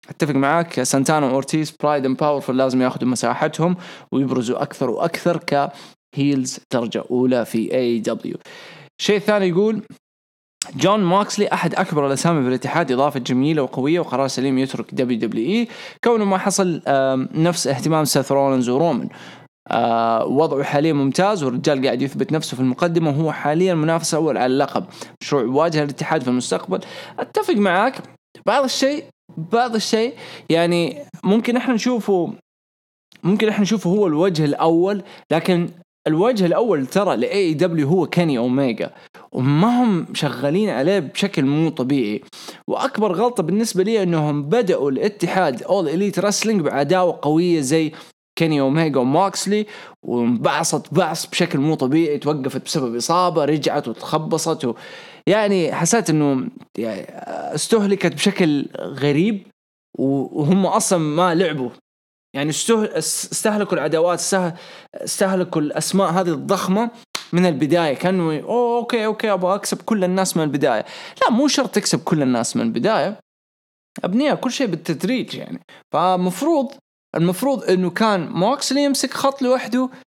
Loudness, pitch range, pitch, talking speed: -19 LUFS, 145-200 Hz, 170 Hz, 130 wpm